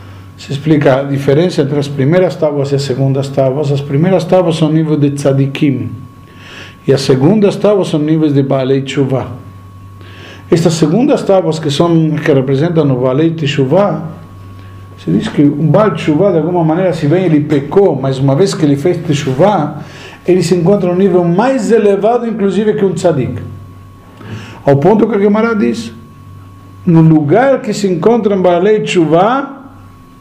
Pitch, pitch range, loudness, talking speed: 155 Hz, 135-185 Hz, -11 LUFS, 165 wpm